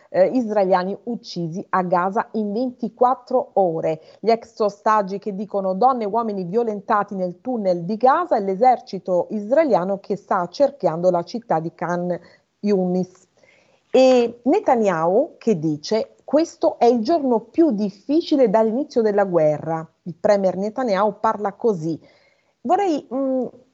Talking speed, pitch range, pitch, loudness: 130 wpm, 185-250 Hz, 215 Hz, -20 LUFS